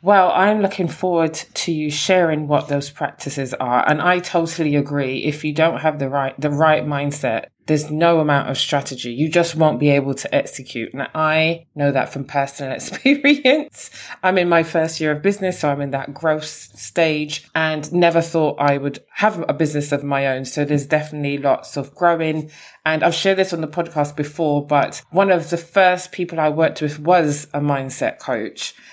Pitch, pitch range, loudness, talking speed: 155 Hz, 145-170 Hz, -19 LUFS, 195 wpm